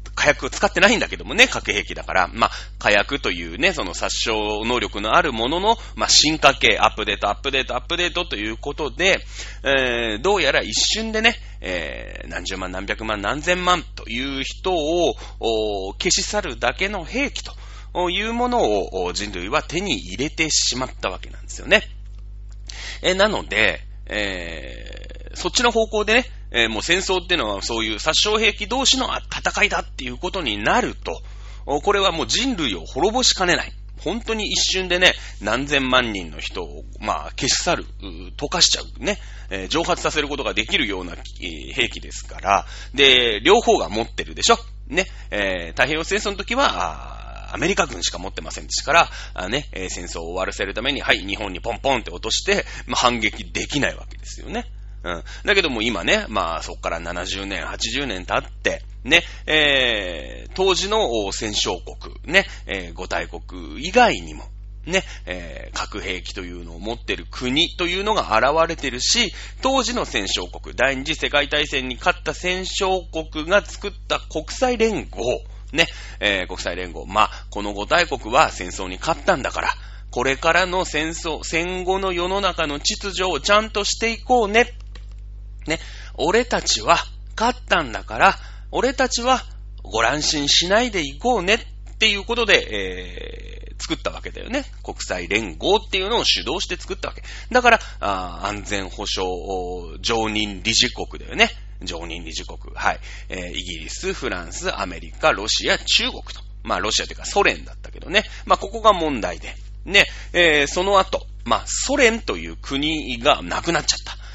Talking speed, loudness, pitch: 330 characters per minute, -20 LUFS, 135 Hz